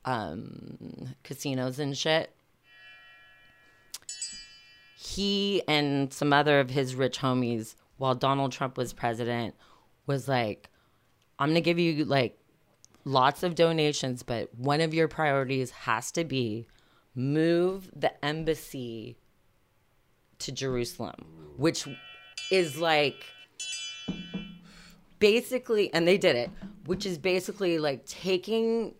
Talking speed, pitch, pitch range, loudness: 110 wpm, 145 Hz, 125-180 Hz, -28 LUFS